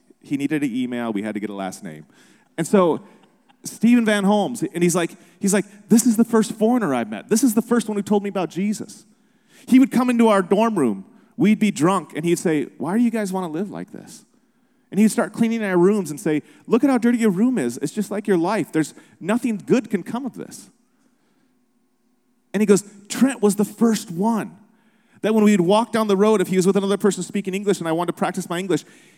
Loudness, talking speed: -20 LUFS, 240 wpm